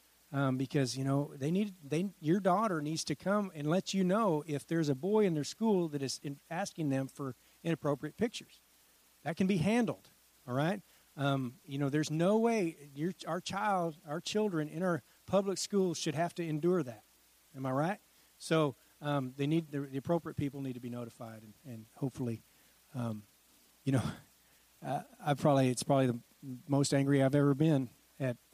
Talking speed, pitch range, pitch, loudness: 190 wpm, 135-175 Hz, 150 Hz, -34 LUFS